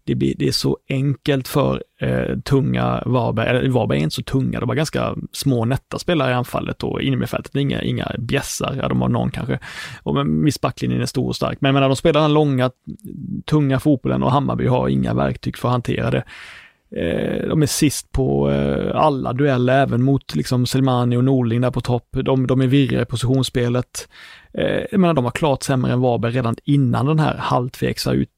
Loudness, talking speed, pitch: -19 LUFS, 205 wpm, 125 Hz